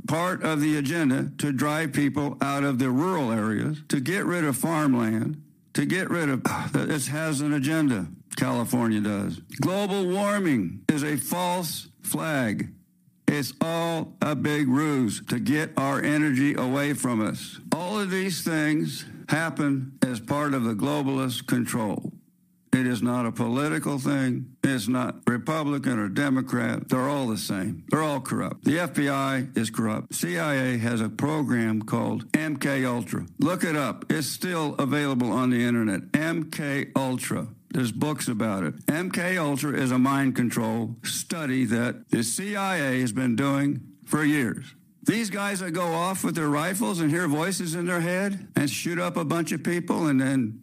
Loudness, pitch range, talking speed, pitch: -26 LUFS, 130-165 Hz, 165 wpm, 145 Hz